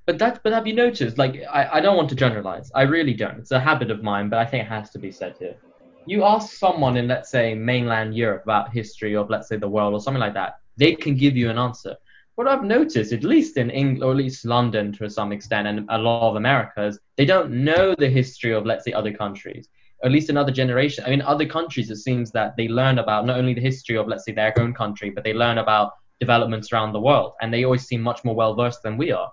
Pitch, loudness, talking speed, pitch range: 120 Hz, -21 LUFS, 260 wpm, 110-140 Hz